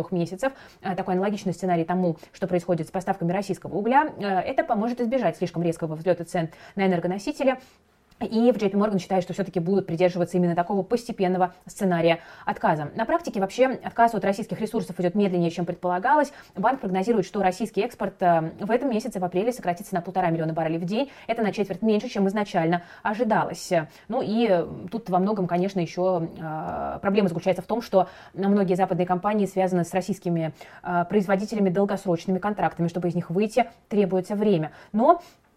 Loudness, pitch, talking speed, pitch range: -25 LUFS, 190 Hz, 165 wpm, 175-210 Hz